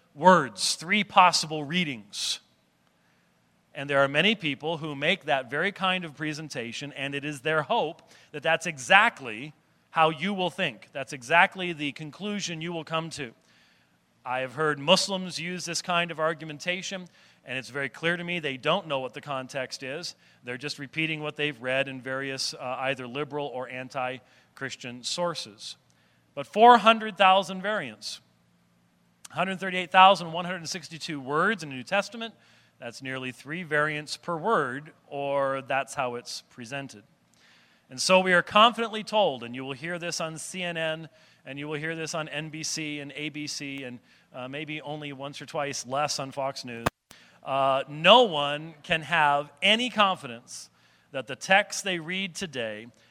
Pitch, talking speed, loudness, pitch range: 150 Hz, 155 wpm, -26 LUFS, 135-175 Hz